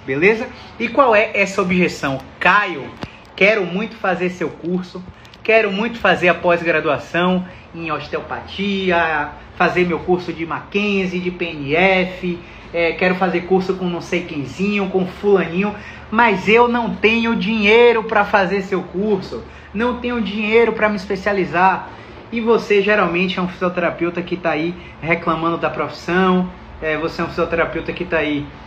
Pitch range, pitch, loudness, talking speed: 170-205 Hz, 180 Hz, -17 LUFS, 150 wpm